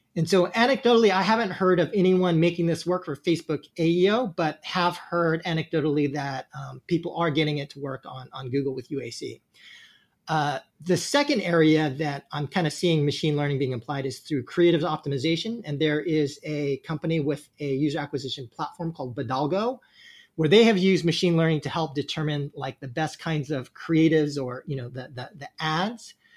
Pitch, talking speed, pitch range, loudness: 155 Hz, 185 wpm, 140-175 Hz, -25 LUFS